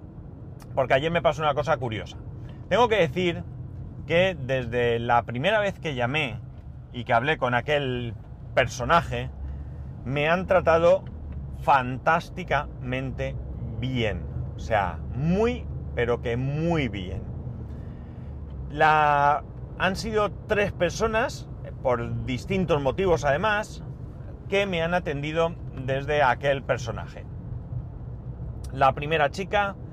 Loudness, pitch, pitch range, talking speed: -25 LUFS, 135 Hz, 120-165 Hz, 110 wpm